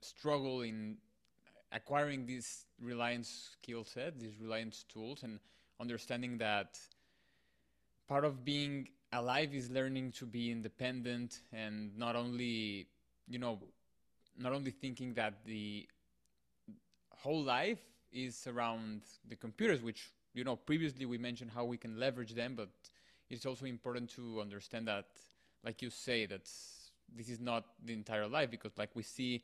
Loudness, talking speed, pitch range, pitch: -41 LUFS, 145 wpm, 110-125 Hz, 120 Hz